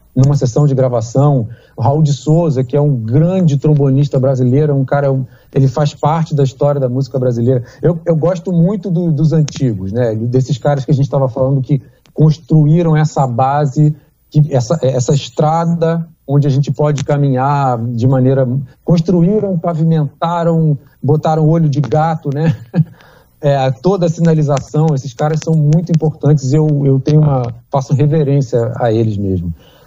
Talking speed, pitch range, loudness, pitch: 160 wpm, 130-155 Hz, -13 LUFS, 145 Hz